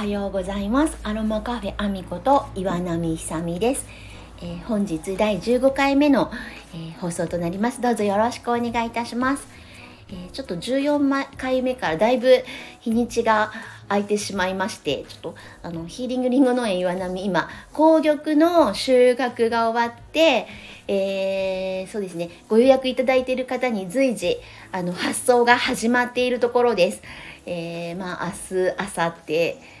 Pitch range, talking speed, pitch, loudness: 190-255 Hz, 320 characters per minute, 230 Hz, -22 LUFS